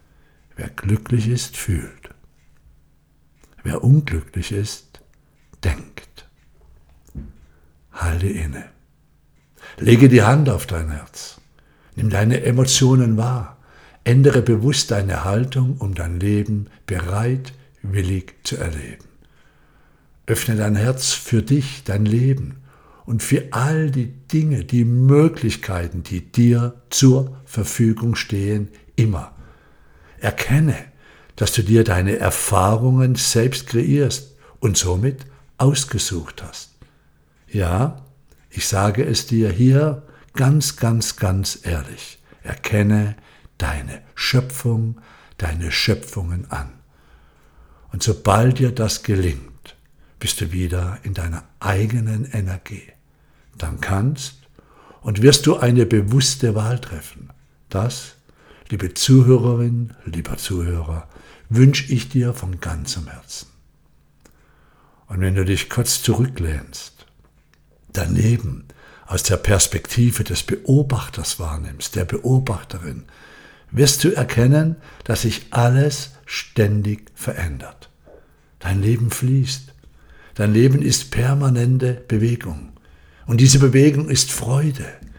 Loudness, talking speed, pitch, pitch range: -19 LUFS, 105 wpm, 110 Hz, 90-130 Hz